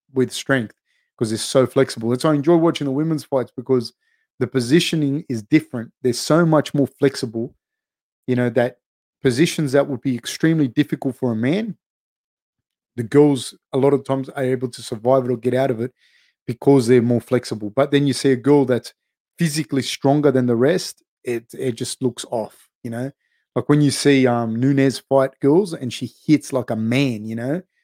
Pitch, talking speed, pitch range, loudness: 135 Hz, 195 wpm, 125-145 Hz, -19 LUFS